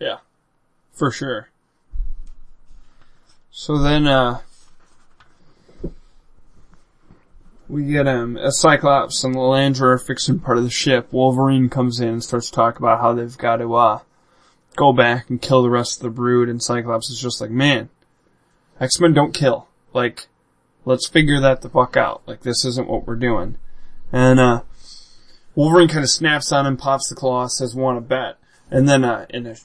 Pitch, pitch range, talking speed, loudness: 130 Hz, 120-140 Hz, 170 wpm, -18 LUFS